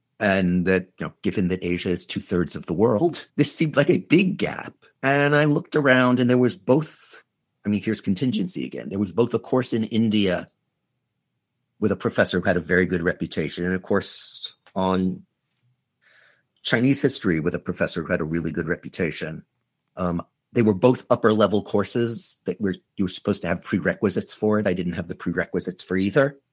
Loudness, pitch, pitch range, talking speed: -23 LUFS, 105 Hz, 90-130 Hz, 195 wpm